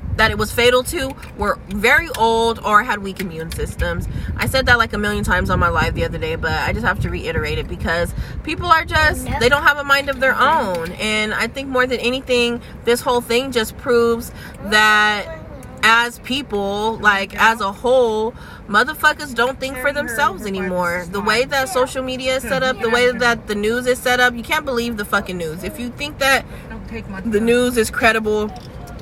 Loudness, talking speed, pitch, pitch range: -17 LUFS, 205 wpm, 235 Hz, 210-255 Hz